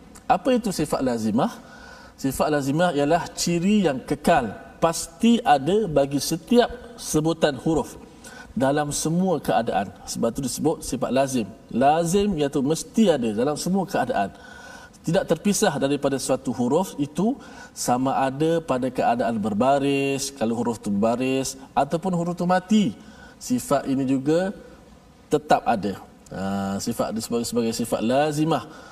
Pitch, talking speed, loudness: 170 Hz, 125 wpm, -23 LUFS